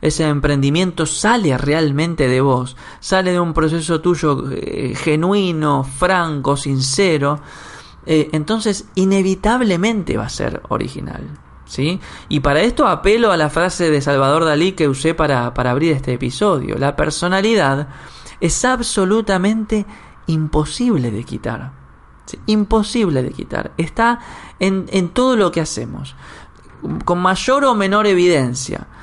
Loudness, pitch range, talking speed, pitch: -17 LUFS, 140-195 Hz, 130 wpm, 165 Hz